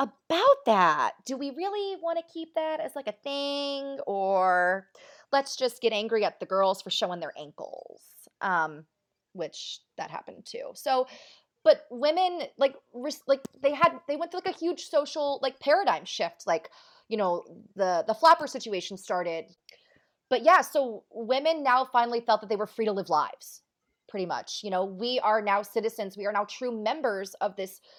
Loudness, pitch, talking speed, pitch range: -28 LUFS, 255 Hz, 180 wpm, 205-295 Hz